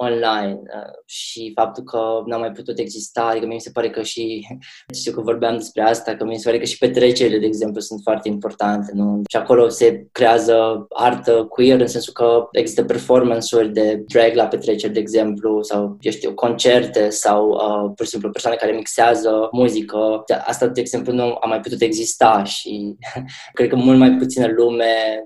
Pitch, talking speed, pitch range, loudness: 115 Hz, 190 wpm, 110-120 Hz, -17 LUFS